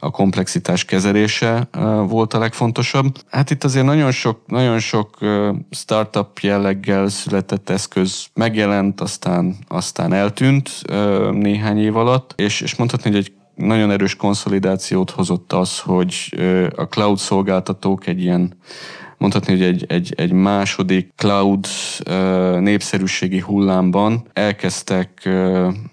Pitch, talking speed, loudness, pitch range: 100 Hz, 130 wpm, -17 LUFS, 95-110 Hz